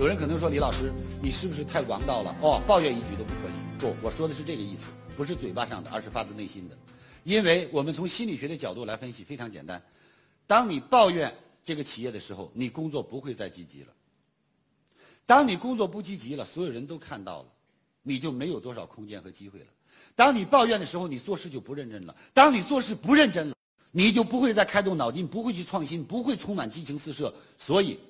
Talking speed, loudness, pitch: 340 characters per minute, -26 LUFS, 150 Hz